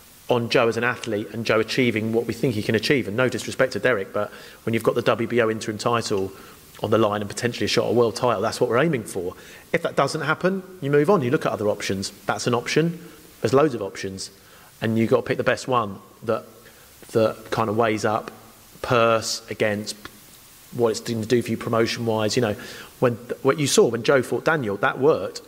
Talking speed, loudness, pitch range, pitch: 235 wpm, -23 LUFS, 110-125 Hz, 115 Hz